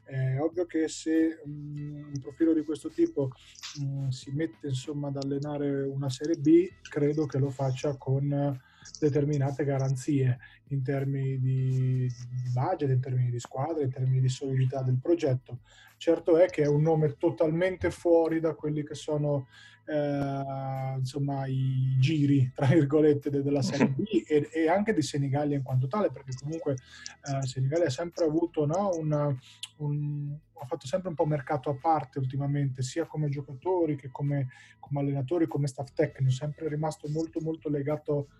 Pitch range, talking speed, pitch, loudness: 135-155 Hz, 155 wpm, 145 Hz, -29 LUFS